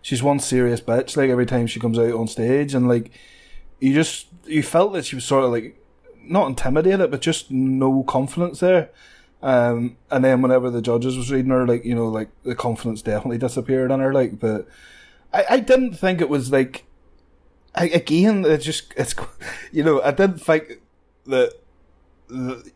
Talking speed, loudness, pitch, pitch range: 185 wpm, -20 LUFS, 130 Hz, 120-155 Hz